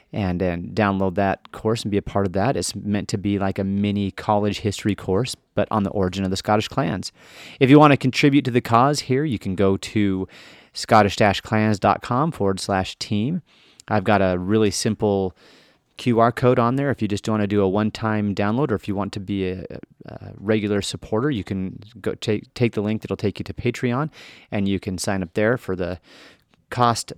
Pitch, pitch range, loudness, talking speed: 105 Hz, 100-115 Hz, -21 LUFS, 215 wpm